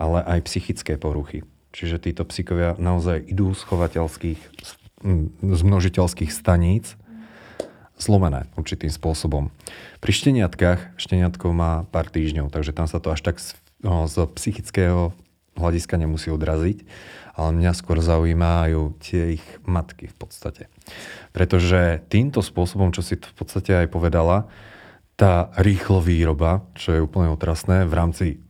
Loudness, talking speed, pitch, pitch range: -22 LUFS, 135 wpm, 85 Hz, 80-95 Hz